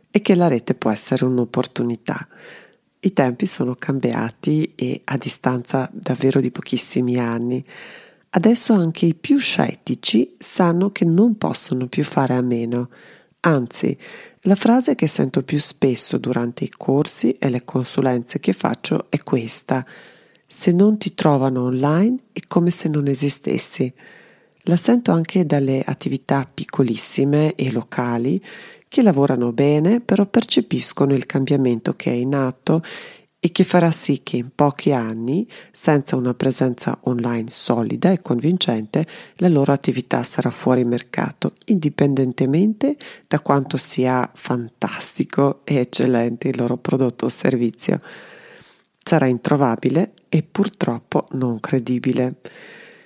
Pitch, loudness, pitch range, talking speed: 140 Hz, -19 LUFS, 125-170 Hz, 130 wpm